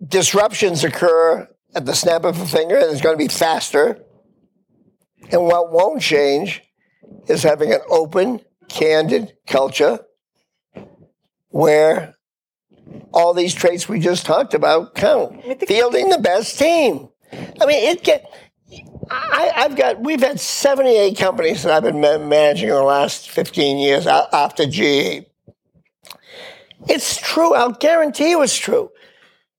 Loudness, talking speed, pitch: -16 LUFS, 135 wpm, 205 Hz